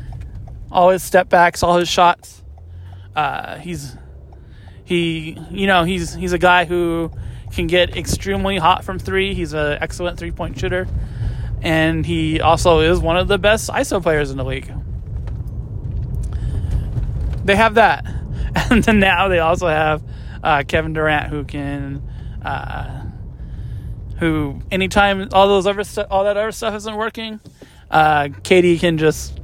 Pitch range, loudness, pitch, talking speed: 115-180 Hz, -17 LUFS, 160 Hz, 145 wpm